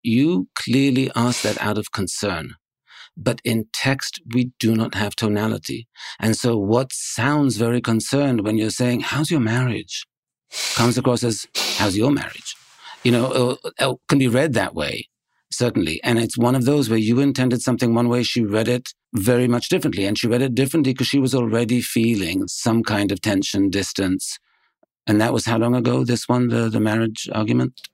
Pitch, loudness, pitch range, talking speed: 120 Hz, -20 LUFS, 110-125 Hz, 185 wpm